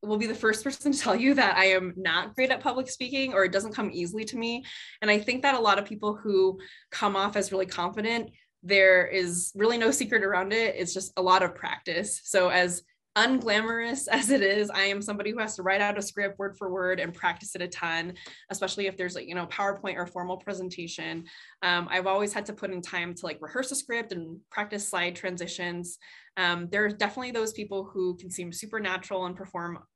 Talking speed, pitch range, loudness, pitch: 225 wpm, 180-220 Hz, -27 LUFS, 195 Hz